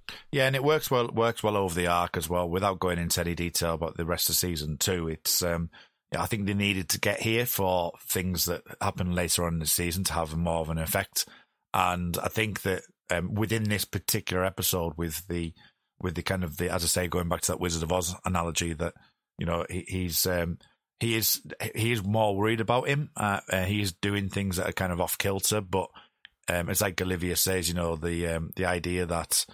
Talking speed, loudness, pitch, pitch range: 230 wpm, -28 LUFS, 90 Hz, 85-100 Hz